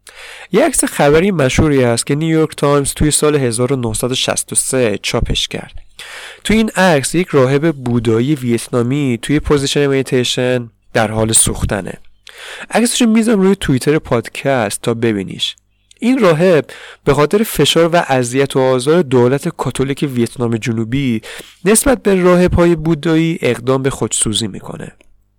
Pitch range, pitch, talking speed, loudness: 120-165 Hz, 140 Hz, 130 wpm, -14 LUFS